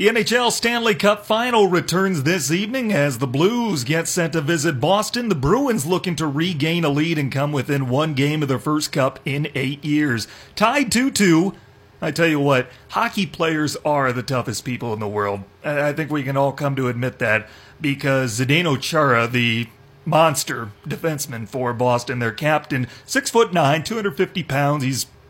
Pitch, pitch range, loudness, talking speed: 150 Hz, 130-180 Hz, -20 LUFS, 185 wpm